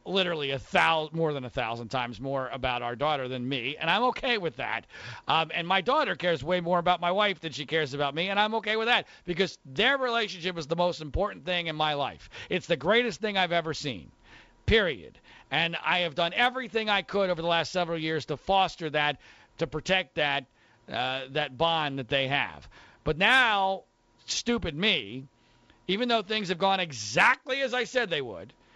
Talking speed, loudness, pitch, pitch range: 200 wpm, -27 LUFS, 170 Hz, 145-195 Hz